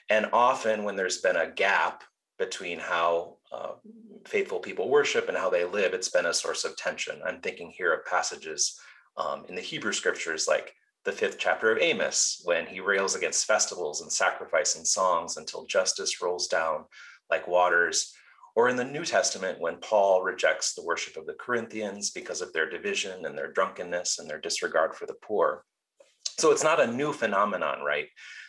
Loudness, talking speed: -27 LUFS, 185 wpm